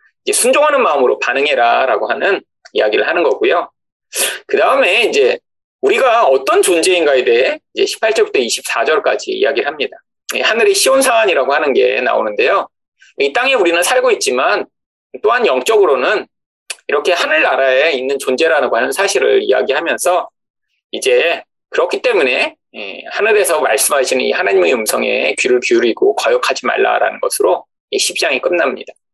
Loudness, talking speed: -13 LUFS, 345 characters per minute